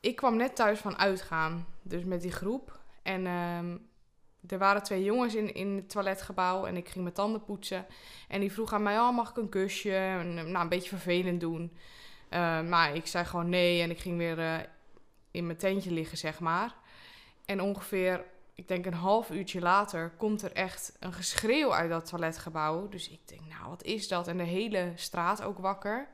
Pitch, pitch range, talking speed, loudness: 185 Hz, 170-200 Hz, 200 wpm, -32 LUFS